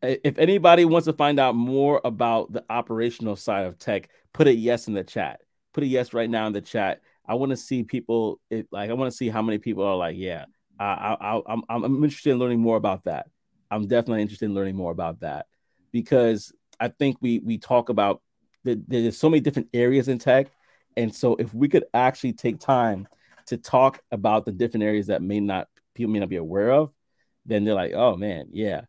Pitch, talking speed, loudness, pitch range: 115 Hz, 220 wpm, -24 LUFS, 105-130 Hz